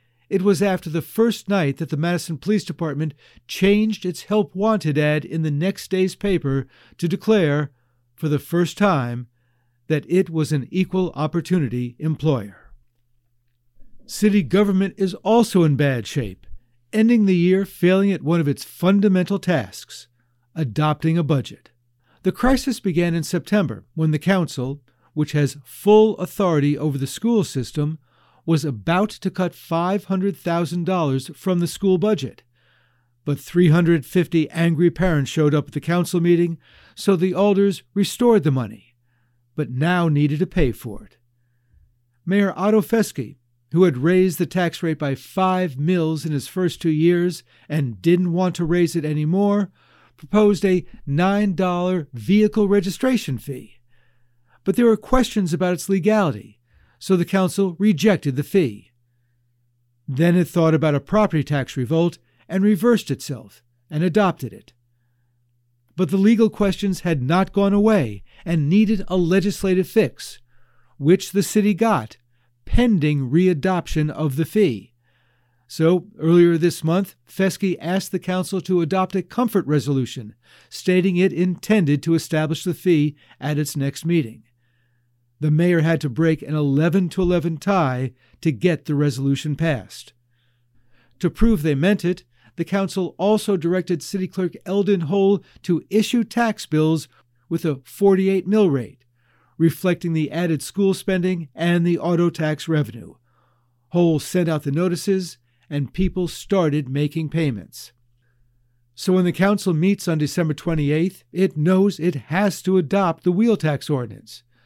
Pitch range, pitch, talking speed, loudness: 135-190 Hz, 165 Hz, 145 wpm, -20 LUFS